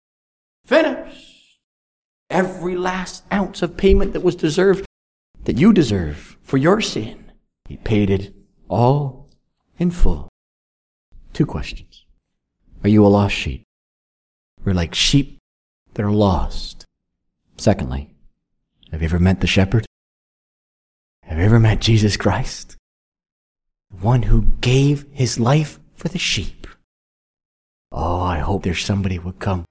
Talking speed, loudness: 125 wpm, -19 LUFS